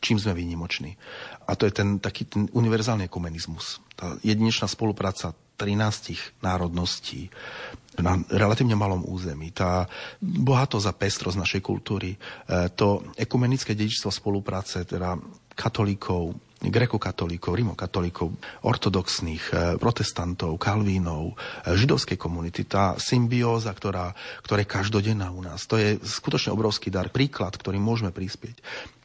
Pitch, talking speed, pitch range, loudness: 100 Hz, 120 wpm, 90-110 Hz, -26 LUFS